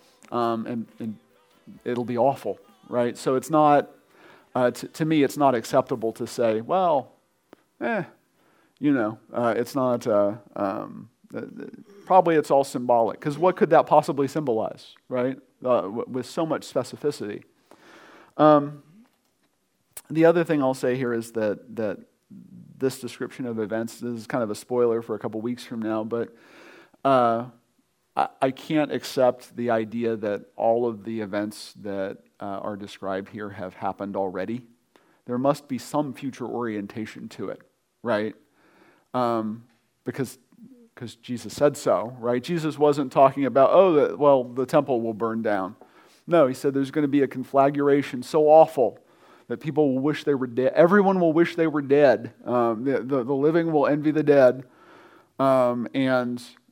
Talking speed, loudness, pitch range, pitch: 165 wpm, -23 LUFS, 115-145 Hz, 125 Hz